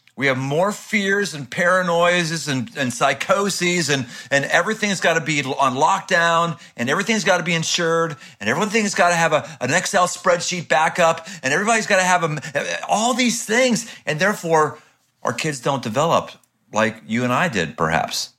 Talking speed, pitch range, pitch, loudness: 175 wpm, 145-195 Hz, 170 Hz, -19 LUFS